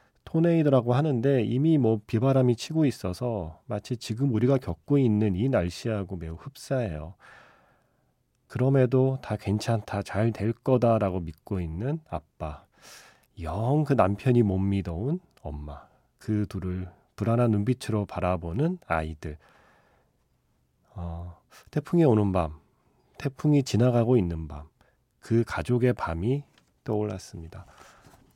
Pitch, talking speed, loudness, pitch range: 110 Hz, 255 characters per minute, -26 LUFS, 90-130 Hz